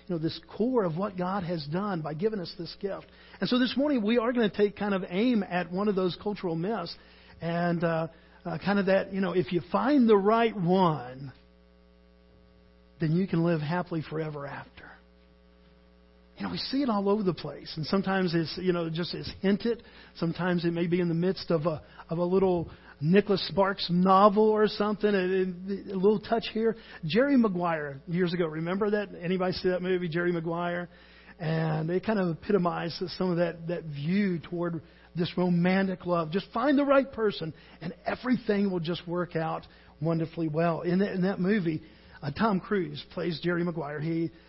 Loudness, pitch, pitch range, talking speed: -28 LUFS, 180 Hz, 165-200 Hz, 195 wpm